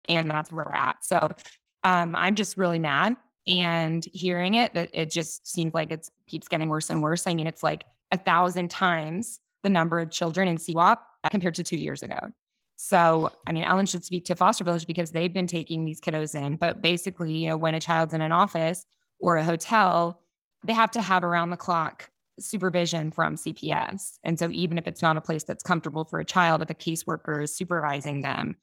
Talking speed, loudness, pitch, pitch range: 210 wpm, -26 LUFS, 170 Hz, 160-180 Hz